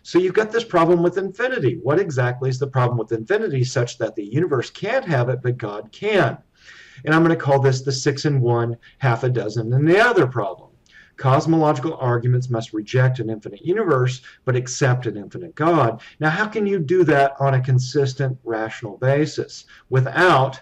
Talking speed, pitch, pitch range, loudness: 190 wpm, 135 Hz, 120-160 Hz, -20 LUFS